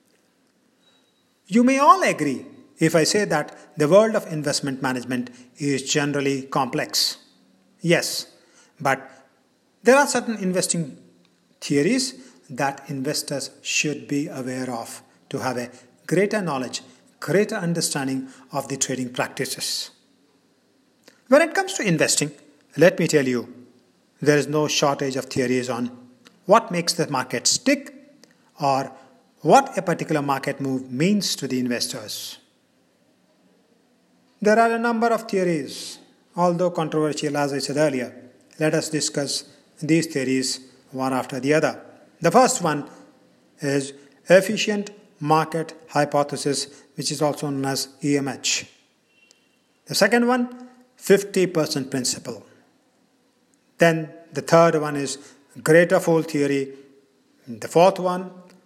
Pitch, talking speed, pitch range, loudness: 150 Hz, 125 wpm, 135-190 Hz, -22 LUFS